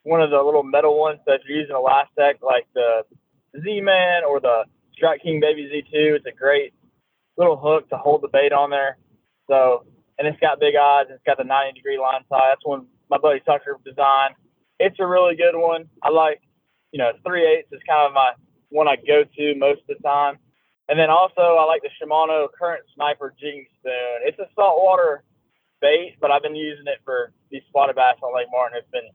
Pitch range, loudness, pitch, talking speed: 135-160 Hz, -19 LUFS, 145 Hz, 210 wpm